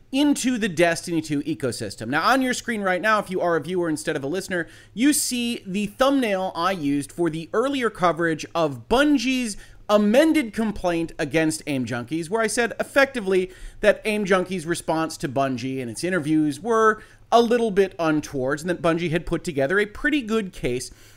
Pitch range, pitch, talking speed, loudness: 160-225 Hz, 180 Hz, 185 wpm, -23 LUFS